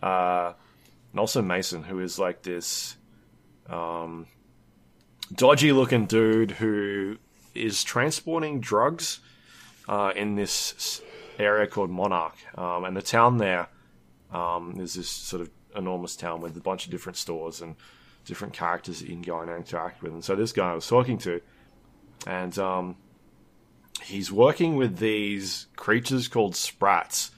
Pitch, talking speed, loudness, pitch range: 95 Hz, 145 wpm, -26 LUFS, 85-110 Hz